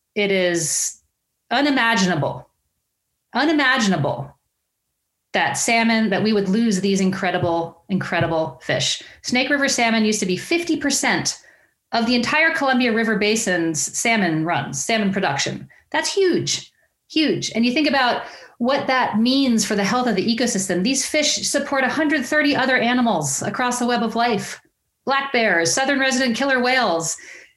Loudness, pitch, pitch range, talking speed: -19 LUFS, 235 Hz, 195-270 Hz, 140 wpm